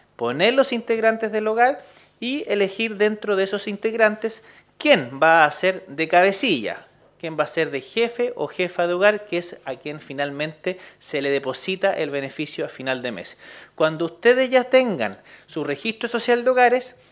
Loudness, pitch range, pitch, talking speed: -21 LUFS, 155-230 Hz, 195 Hz, 175 wpm